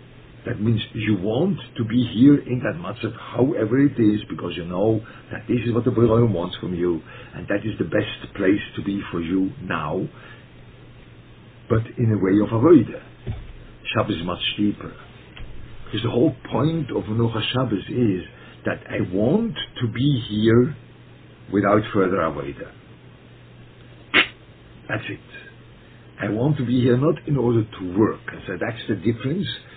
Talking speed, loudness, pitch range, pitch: 160 wpm, -22 LUFS, 105-125 Hz, 115 Hz